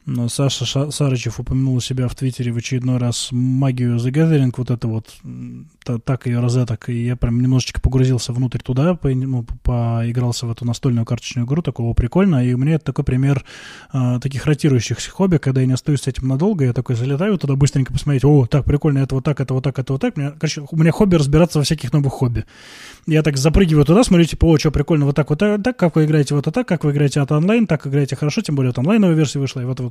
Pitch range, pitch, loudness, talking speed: 125-150 Hz, 135 Hz, -18 LUFS, 245 wpm